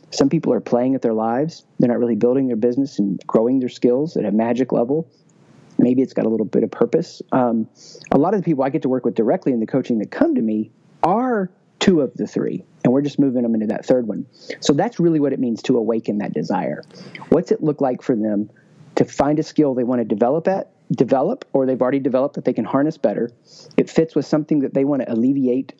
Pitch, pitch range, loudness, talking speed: 130 Hz, 120-155 Hz, -19 LUFS, 245 wpm